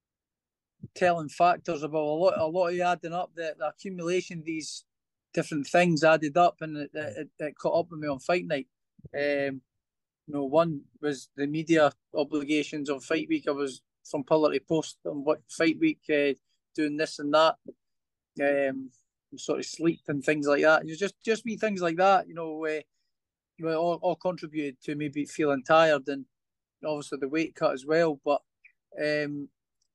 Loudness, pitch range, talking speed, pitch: -28 LUFS, 145-165 Hz, 180 wpm, 155 Hz